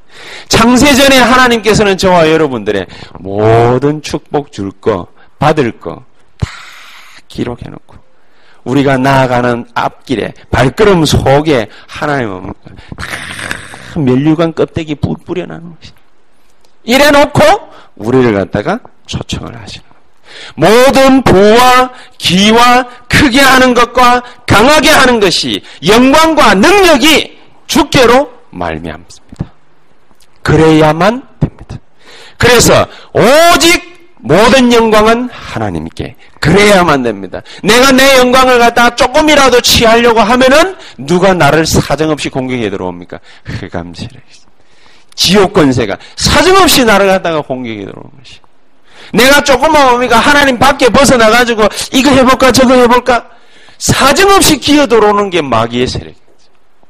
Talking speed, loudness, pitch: 265 characters per minute, -7 LUFS, 215 Hz